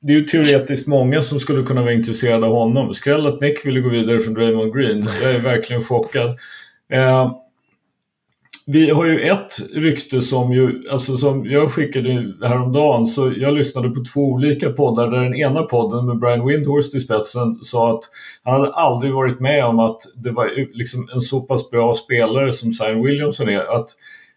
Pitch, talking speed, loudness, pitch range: 130 Hz, 185 wpm, -17 LUFS, 120-145 Hz